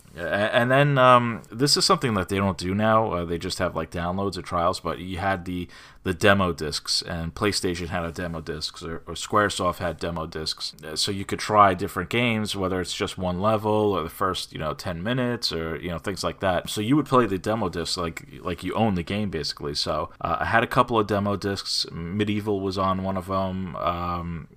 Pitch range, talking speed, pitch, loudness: 90-105 Hz, 225 wpm, 95 Hz, -24 LUFS